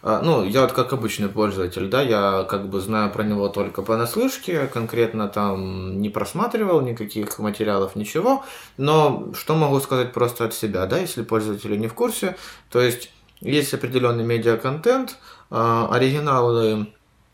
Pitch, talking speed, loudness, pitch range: 115 Hz, 145 wpm, -22 LUFS, 105-135 Hz